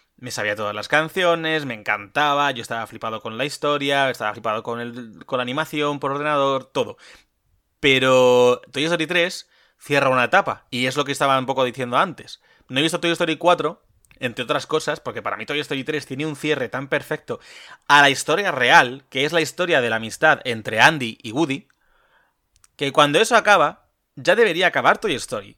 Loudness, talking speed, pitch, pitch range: -20 LUFS, 195 wpm, 140 Hz, 125-155 Hz